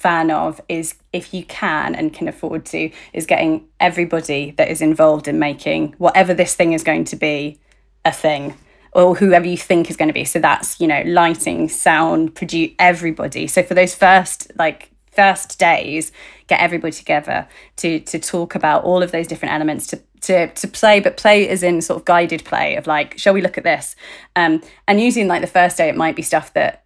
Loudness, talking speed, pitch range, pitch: -16 LUFS, 210 wpm, 160-190 Hz, 175 Hz